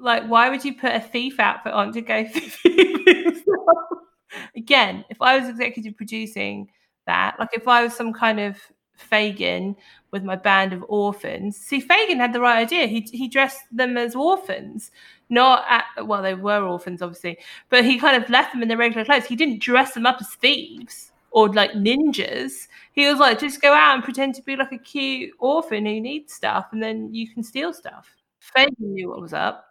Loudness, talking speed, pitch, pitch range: -19 LUFS, 200 wpm, 245 Hz, 220-275 Hz